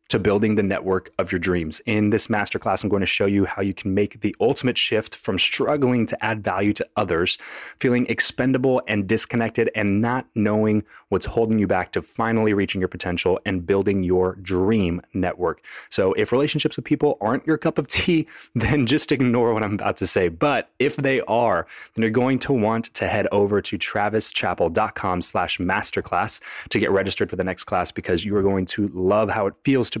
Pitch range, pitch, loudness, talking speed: 95-120 Hz, 105 Hz, -22 LUFS, 200 wpm